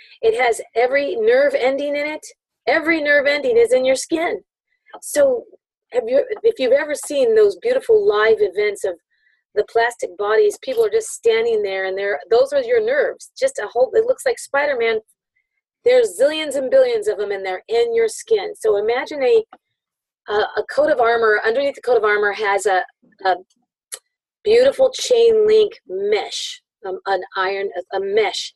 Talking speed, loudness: 175 wpm, -18 LUFS